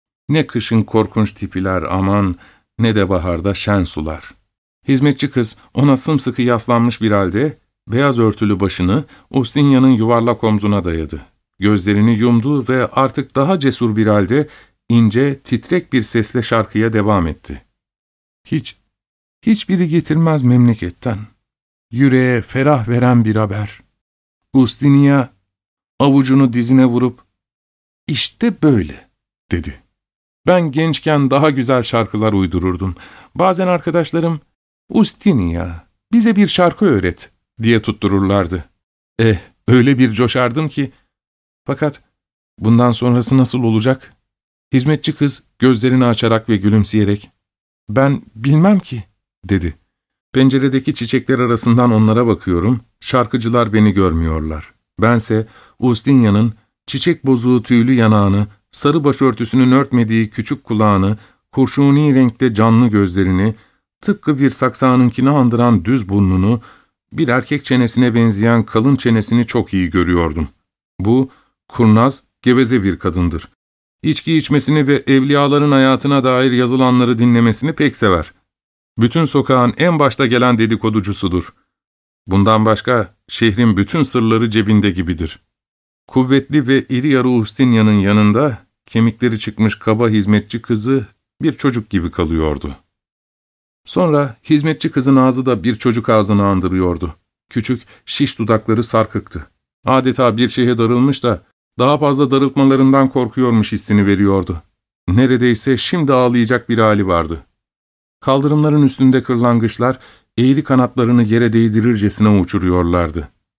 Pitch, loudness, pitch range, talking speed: 120 Hz, -14 LUFS, 105-130 Hz, 110 wpm